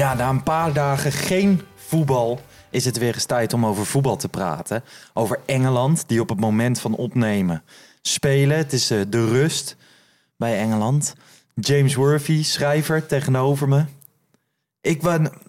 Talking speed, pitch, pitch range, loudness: 150 wpm, 140 Hz, 120-150 Hz, -21 LUFS